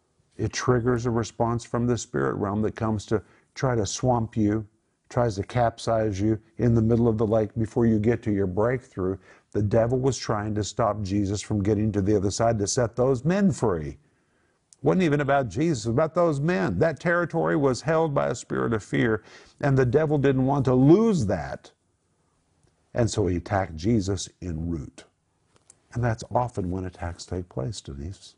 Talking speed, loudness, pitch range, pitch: 190 wpm, -25 LUFS, 105-130 Hz, 115 Hz